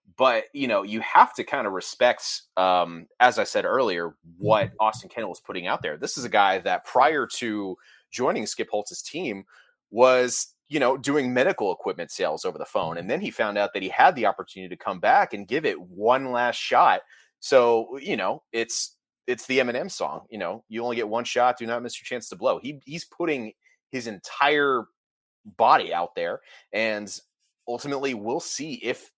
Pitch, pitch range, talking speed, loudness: 120 Hz, 105-135 Hz, 195 wpm, -24 LUFS